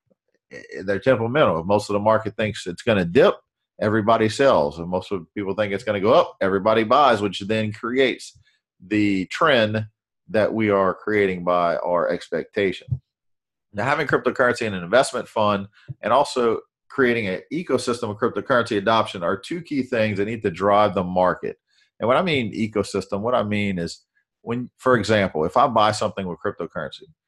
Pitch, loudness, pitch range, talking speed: 105 Hz, -21 LUFS, 100-115 Hz, 180 wpm